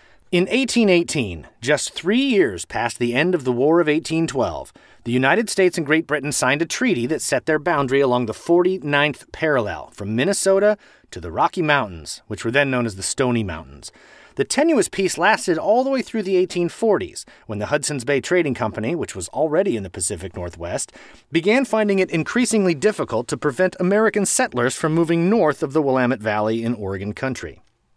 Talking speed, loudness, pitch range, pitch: 185 wpm, -20 LUFS, 120-185 Hz, 150 Hz